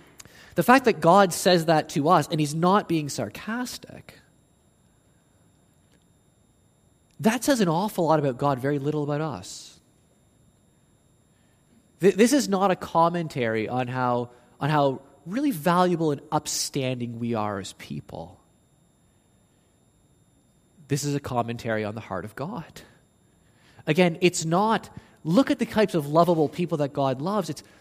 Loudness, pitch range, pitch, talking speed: -24 LUFS, 130-185 Hz, 155 Hz, 140 wpm